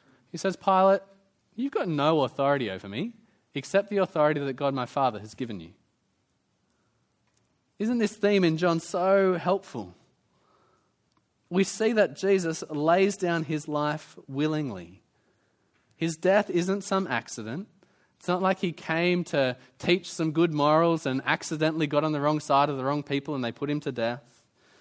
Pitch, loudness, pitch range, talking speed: 160 Hz, -27 LUFS, 140-190 Hz, 160 wpm